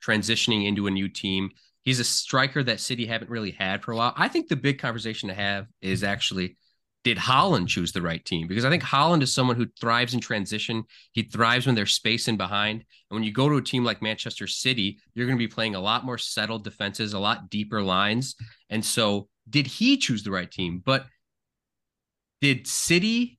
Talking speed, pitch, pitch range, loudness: 215 wpm, 110 Hz, 100-125 Hz, -25 LUFS